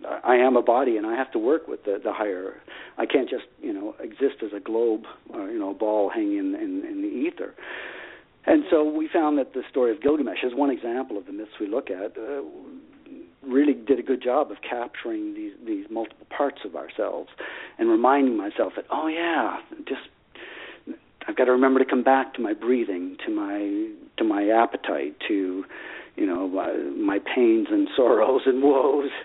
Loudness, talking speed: -24 LUFS, 200 wpm